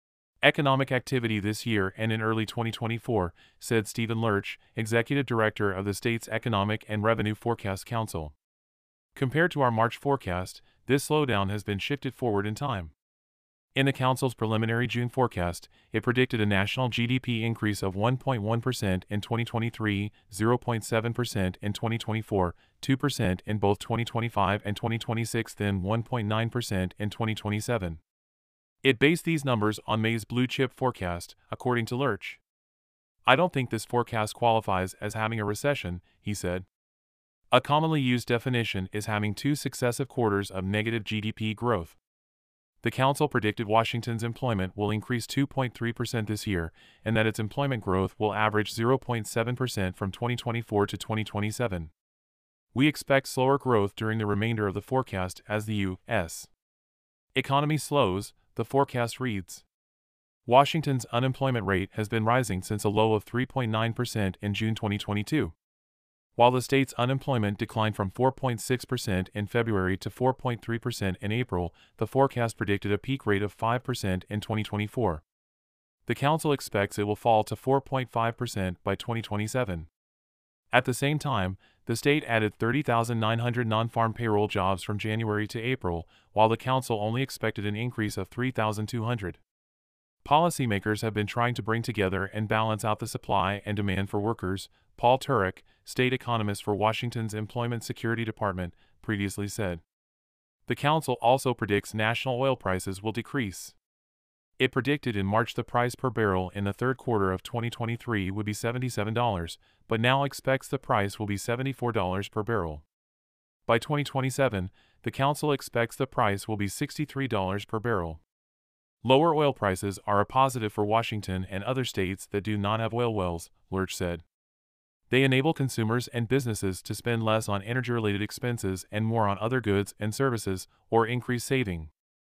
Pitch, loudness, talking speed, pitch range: 110 Hz, -28 LUFS, 150 wpm, 100-120 Hz